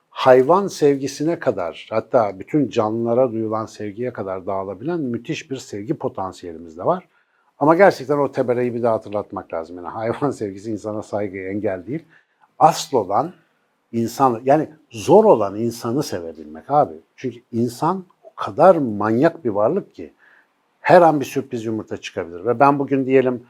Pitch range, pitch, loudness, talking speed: 105-140 Hz, 120 Hz, -19 LUFS, 150 wpm